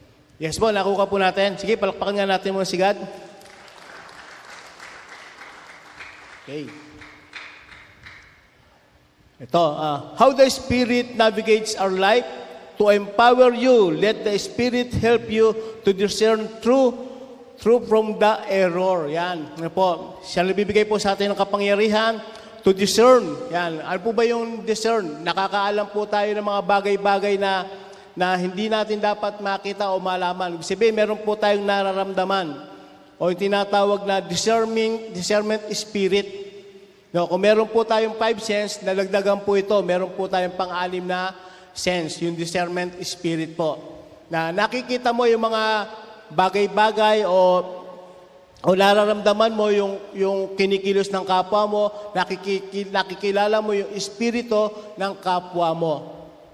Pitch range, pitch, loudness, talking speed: 185-215 Hz, 200 Hz, -21 LUFS, 135 wpm